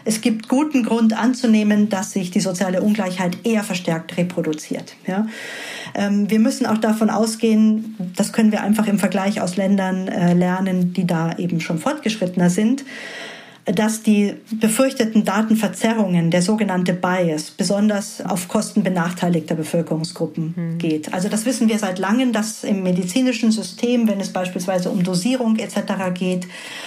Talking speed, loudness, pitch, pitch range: 145 wpm, -19 LUFS, 205 Hz, 185-225 Hz